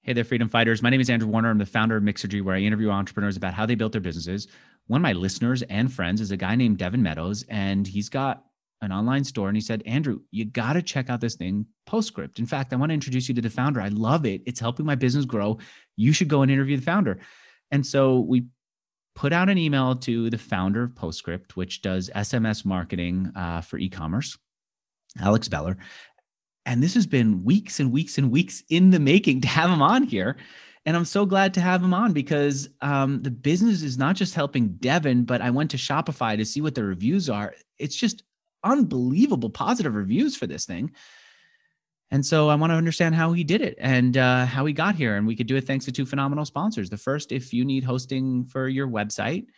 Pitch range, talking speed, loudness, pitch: 110-150 Hz, 230 wpm, -24 LUFS, 130 Hz